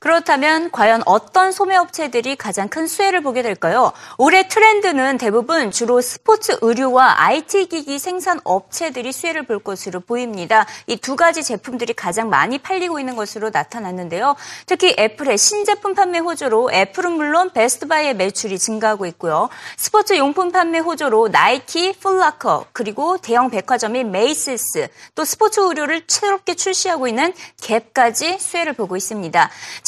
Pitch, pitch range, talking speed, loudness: 295 Hz, 225-365 Hz, 360 characters per minute, -17 LUFS